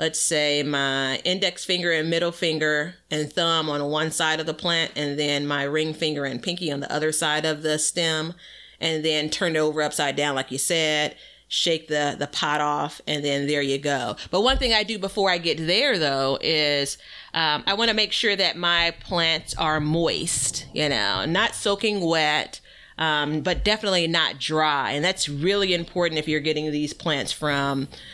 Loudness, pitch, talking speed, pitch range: -23 LUFS, 155 Hz, 195 wpm, 145-170 Hz